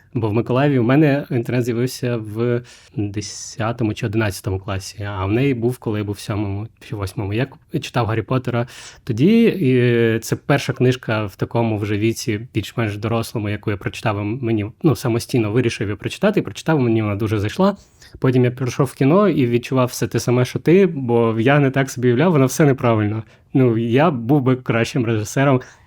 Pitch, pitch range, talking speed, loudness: 120 Hz, 110-130 Hz, 190 wpm, -19 LUFS